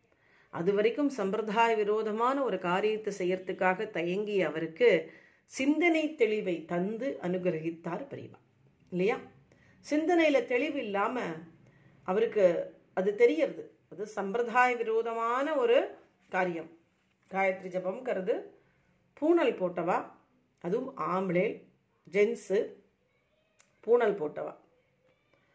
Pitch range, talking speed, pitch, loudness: 185-265 Hz, 80 wpm, 210 Hz, -30 LUFS